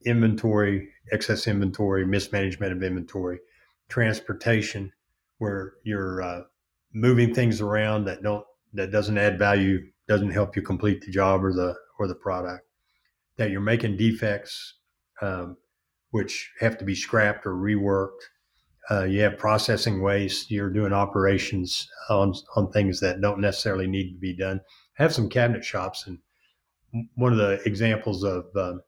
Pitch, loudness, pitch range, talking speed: 100 Hz, -25 LUFS, 95-110 Hz, 150 wpm